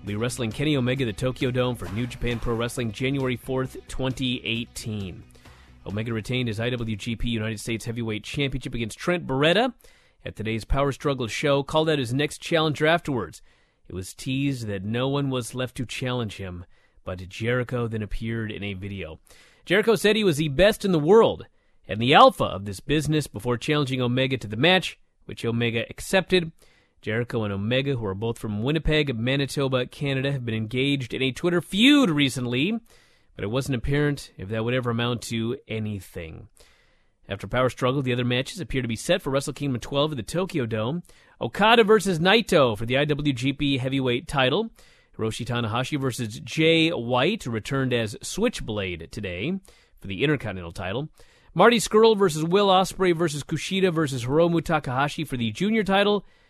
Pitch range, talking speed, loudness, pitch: 115-155 Hz, 170 wpm, -24 LUFS, 130 Hz